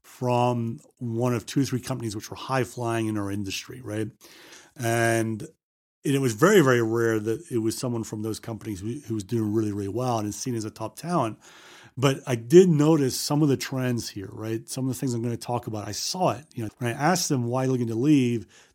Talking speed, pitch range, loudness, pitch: 235 wpm, 110-130 Hz, -25 LUFS, 120 Hz